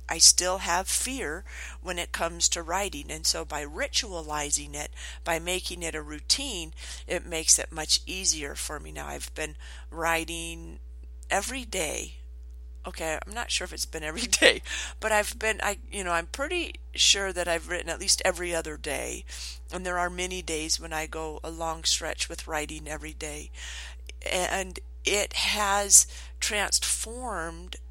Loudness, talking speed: -26 LUFS, 165 wpm